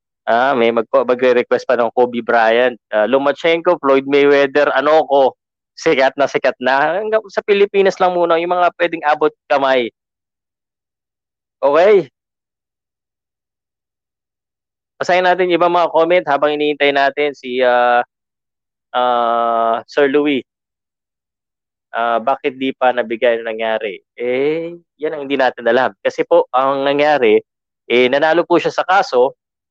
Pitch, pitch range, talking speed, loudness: 140 Hz, 120-165 Hz, 130 wpm, -15 LUFS